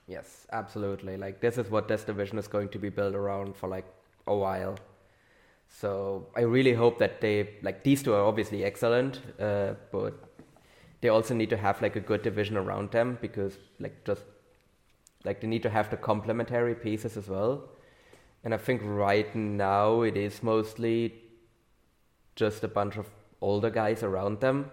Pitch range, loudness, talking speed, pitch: 100-115 Hz, -30 LUFS, 175 wpm, 105 Hz